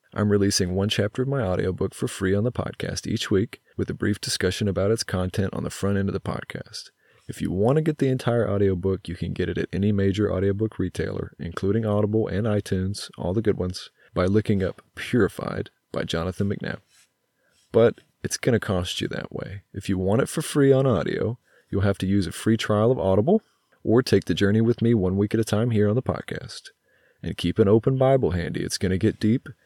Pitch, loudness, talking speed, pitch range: 100 Hz, -24 LUFS, 225 wpm, 95-110 Hz